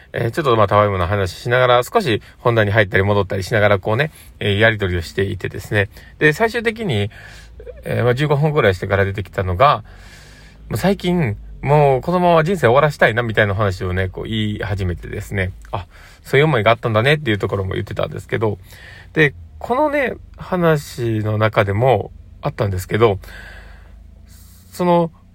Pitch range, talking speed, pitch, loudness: 95-130 Hz, 370 characters per minute, 105 Hz, -17 LUFS